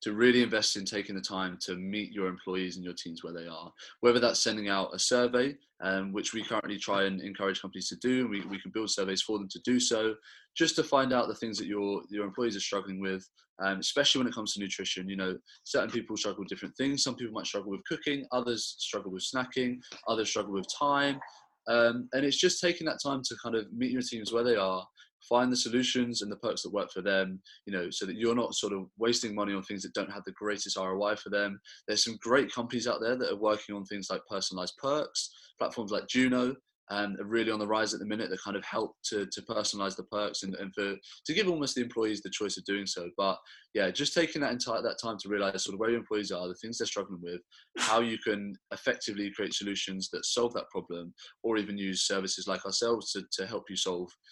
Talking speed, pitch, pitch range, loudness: 245 wpm, 105 Hz, 95-120 Hz, -31 LUFS